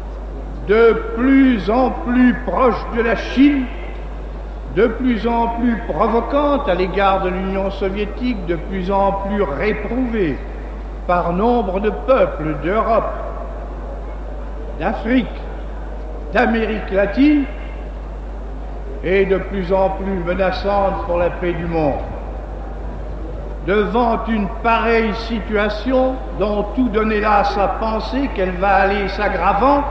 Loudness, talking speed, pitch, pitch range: -18 LUFS, 110 wpm, 205 Hz, 190-235 Hz